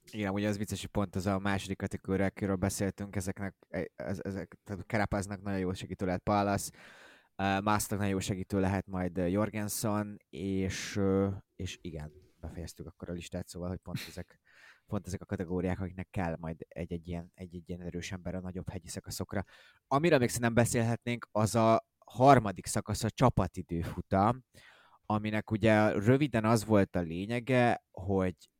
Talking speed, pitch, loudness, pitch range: 160 wpm, 100 Hz, -32 LUFS, 90-105 Hz